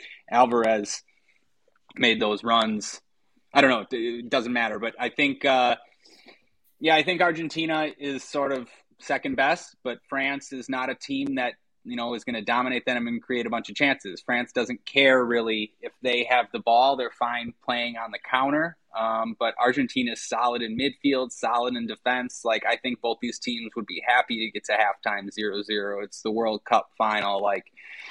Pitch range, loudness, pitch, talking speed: 115-135 Hz, -25 LUFS, 120 Hz, 190 wpm